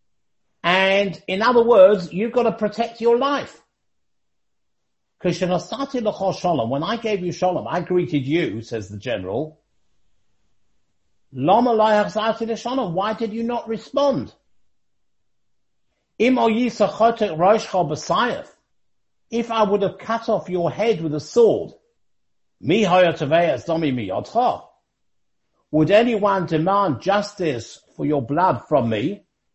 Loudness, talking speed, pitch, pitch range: -20 LUFS, 95 wpm, 200 Hz, 165-230 Hz